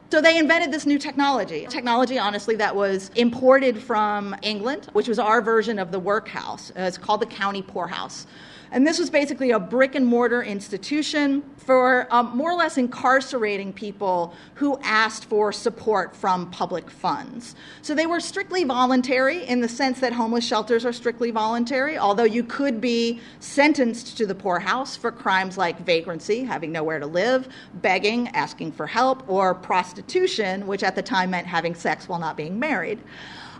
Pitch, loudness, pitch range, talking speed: 235 Hz, -22 LUFS, 200-260 Hz, 170 wpm